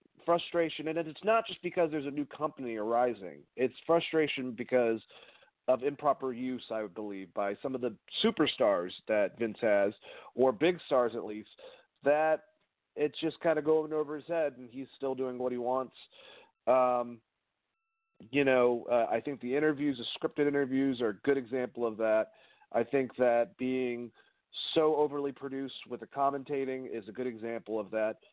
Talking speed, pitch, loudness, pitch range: 175 wpm, 135 Hz, -32 LUFS, 120-155 Hz